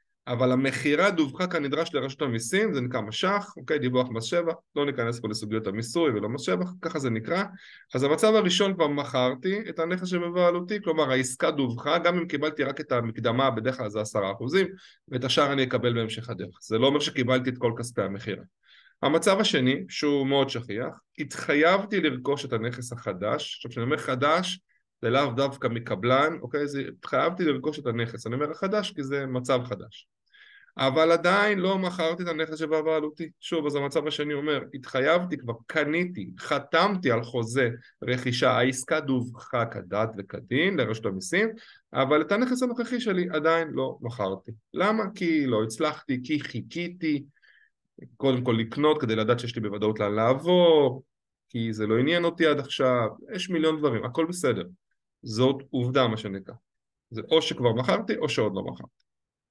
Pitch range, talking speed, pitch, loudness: 120-165 Hz, 155 wpm, 140 Hz, -26 LUFS